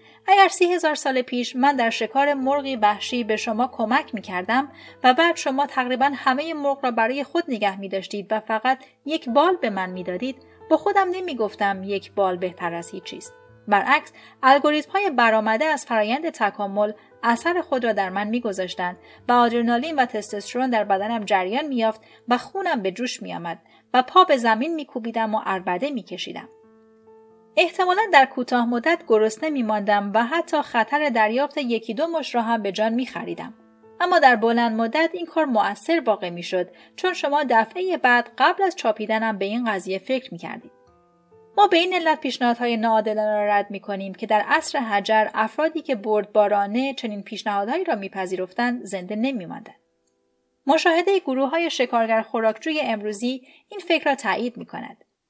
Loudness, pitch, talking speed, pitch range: -22 LUFS, 235 Hz, 170 wpm, 210-290 Hz